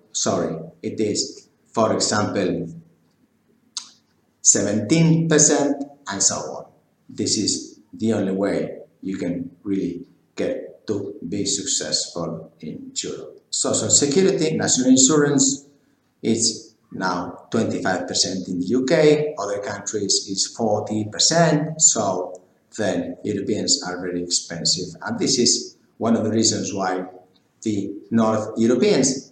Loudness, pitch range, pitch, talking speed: -20 LUFS, 95-150 Hz, 110 Hz, 115 wpm